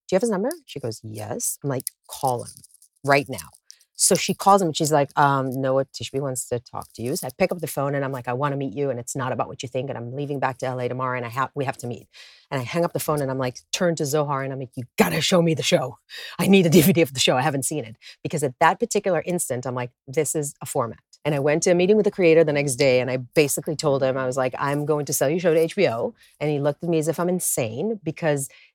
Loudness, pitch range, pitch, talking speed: -23 LUFS, 130-165 Hz, 145 Hz, 305 wpm